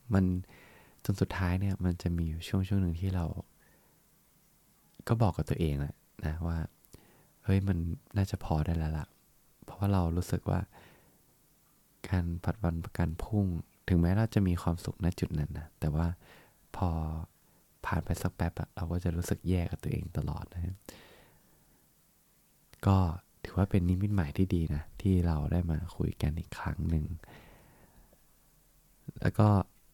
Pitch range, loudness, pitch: 80-95 Hz, -33 LUFS, 90 Hz